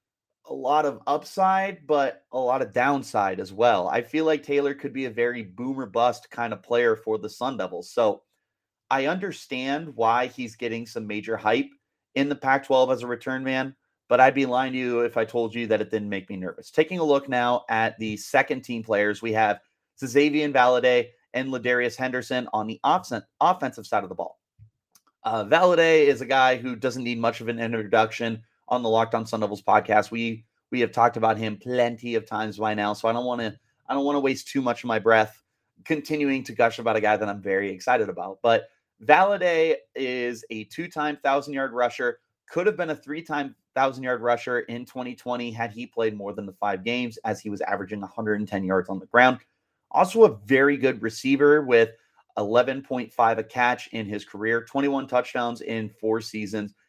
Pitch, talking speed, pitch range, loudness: 120 Hz, 205 wpm, 110-135 Hz, -24 LUFS